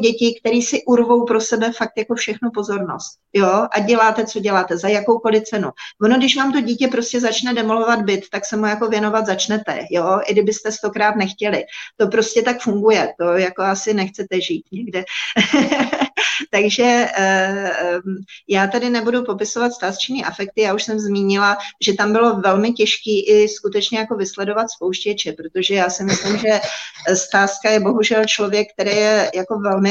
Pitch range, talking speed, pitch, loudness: 195-230 Hz, 165 wpm, 210 Hz, -17 LUFS